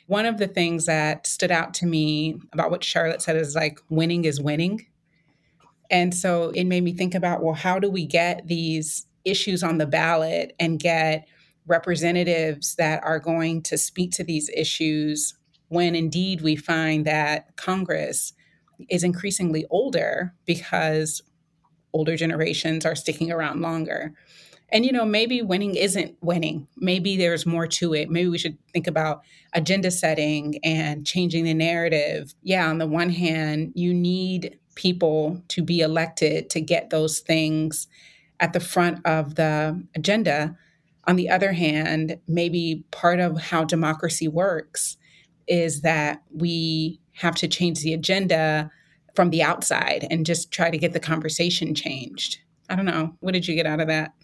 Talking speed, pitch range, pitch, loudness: 160 wpm, 155-175 Hz, 165 Hz, -23 LUFS